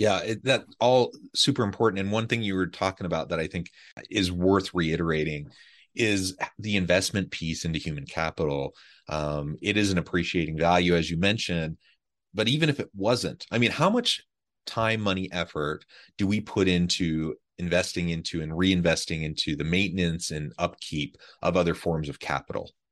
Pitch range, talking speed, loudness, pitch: 80-100 Hz, 170 wpm, -27 LUFS, 90 Hz